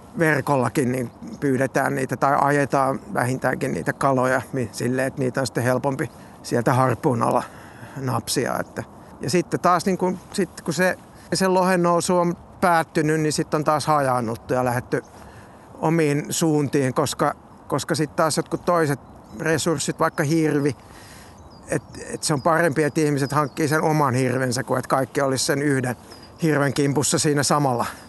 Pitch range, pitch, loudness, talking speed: 130-160 Hz, 145 Hz, -22 LUFS, 155 wpm